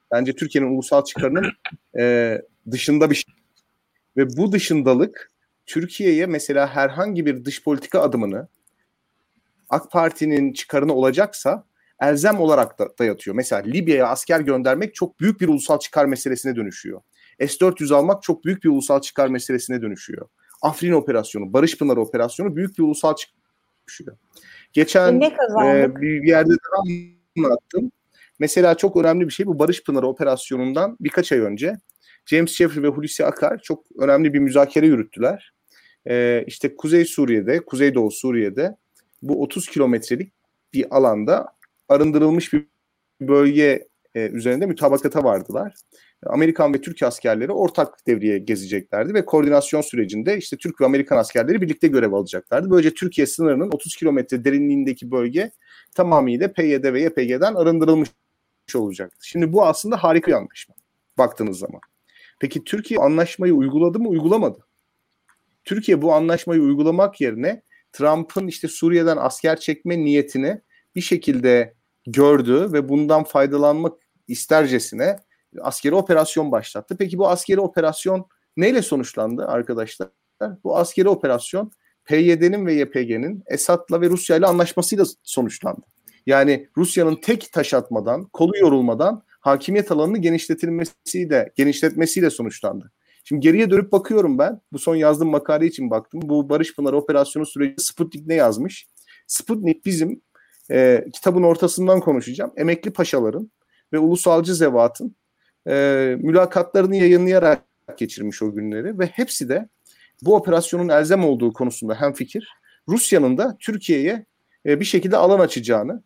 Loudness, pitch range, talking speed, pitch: -19 LUFS, 140-180 Hz, 130 wpm, 160 Hz